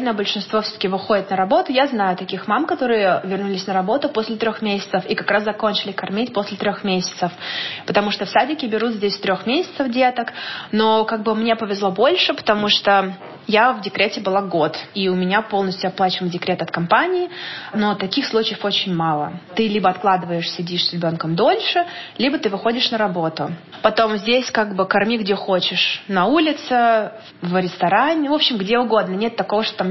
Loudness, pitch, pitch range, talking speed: -19 LUFS, 205 Hz, 190-225 Hz, 180 wpm